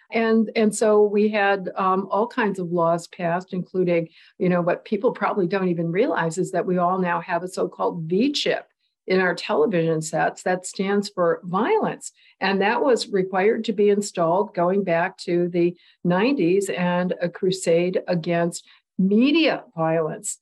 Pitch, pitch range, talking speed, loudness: 185 Hz, 175-210 Hz, 160 wpm, -22 LUFS